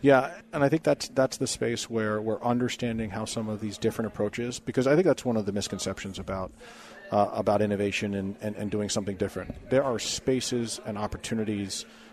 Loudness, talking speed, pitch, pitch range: -28 LUFS, 215 wpm, 110 Hz, 105-120 Hz